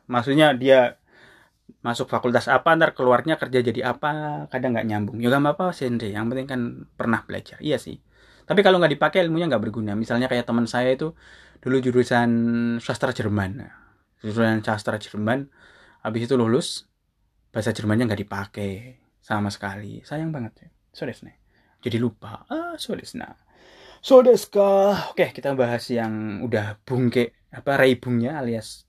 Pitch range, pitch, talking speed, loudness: 110-140 Hz, 120 Hz, 145 wpm, -22 LUFS